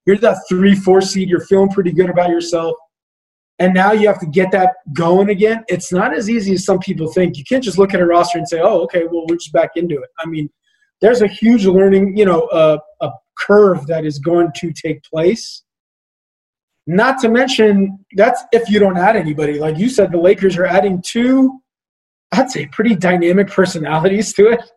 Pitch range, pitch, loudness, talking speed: 170-205 Hz, 185 Hz, -14 LUFS, 210 wpm